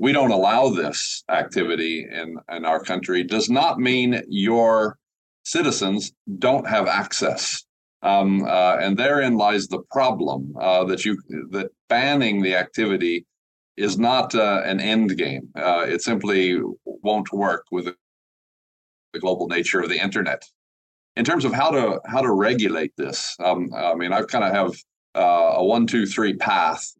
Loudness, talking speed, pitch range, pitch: -21 LUFS, 160 wpm, 85-105 Hz, 95 Hz